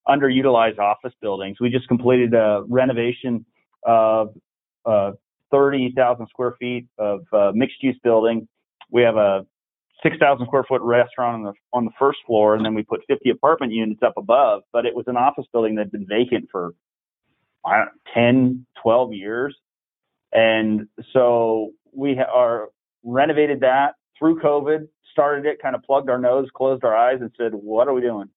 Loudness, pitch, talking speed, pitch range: -20 LUFS, 120 Hz, 175 wpm, 110-130 Hz